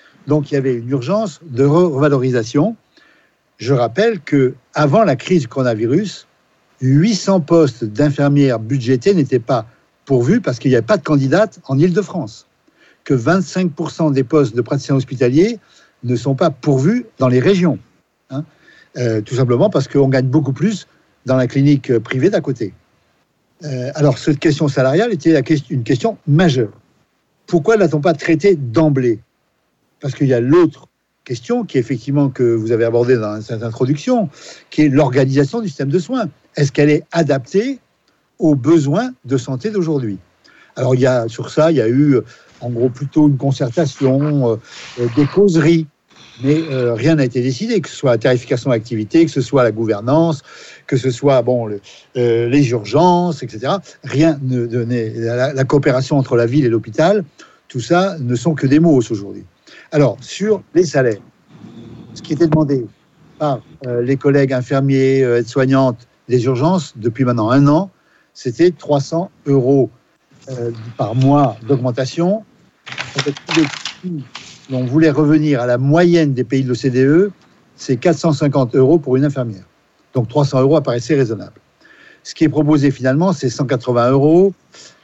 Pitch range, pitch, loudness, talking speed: 125-160 Hz, 140 Hz, -15 LUFS, 165 wpm